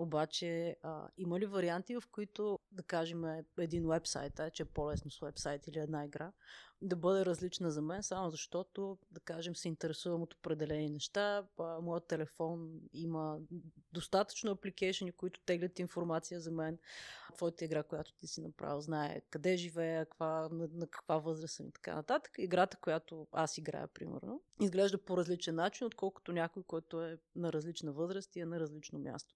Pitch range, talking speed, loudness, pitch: 160-180 Hz, 170 wpm, -40 LUFS, 165 Hz